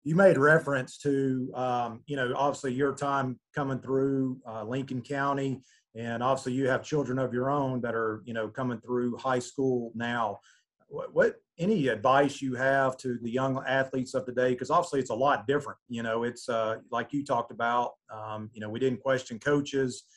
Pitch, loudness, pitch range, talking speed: 130 Hz, -29 LUFS, 120-140 Hz, 195 wpm